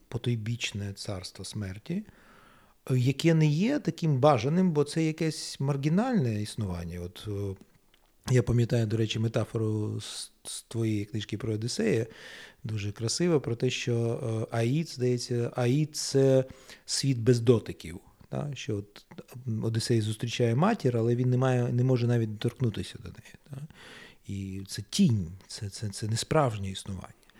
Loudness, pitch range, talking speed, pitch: -29 LUFS, 105-135 Hz, 140 wpm, 120 Hz